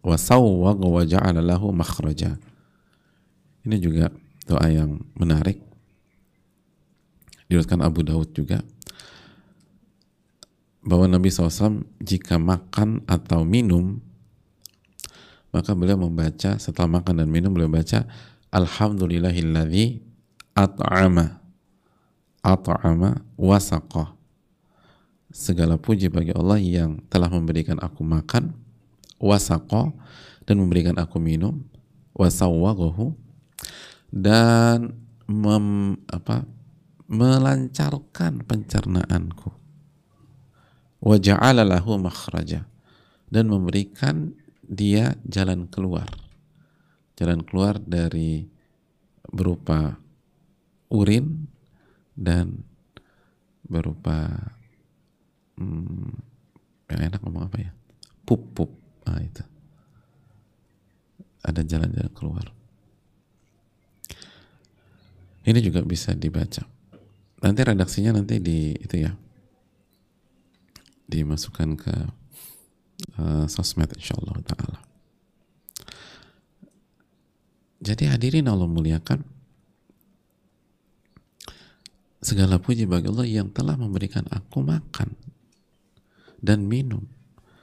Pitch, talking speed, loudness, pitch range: 100 Hz, 75 wpm, -22 LUFS, 85-115 Hz